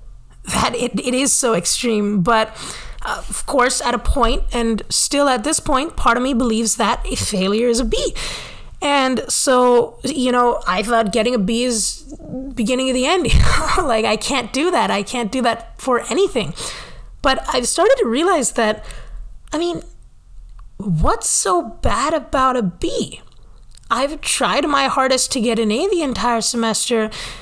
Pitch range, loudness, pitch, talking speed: 230-275 Hz, -17 LUFS, 245 Hz, 175 wpm